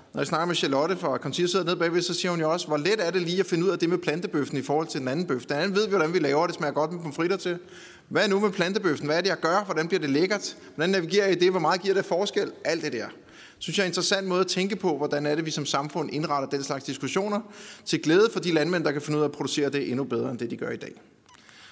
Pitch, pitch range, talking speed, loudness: 170 Hz, 150-190 Hz, 315 wpm, -26 LUFS